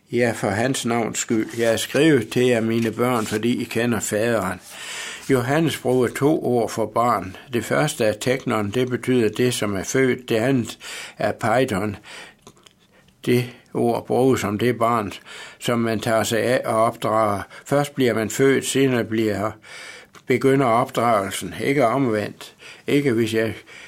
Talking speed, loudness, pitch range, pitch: 155 wpm, -21 LUFS, 110-125 Hz, 115 Hz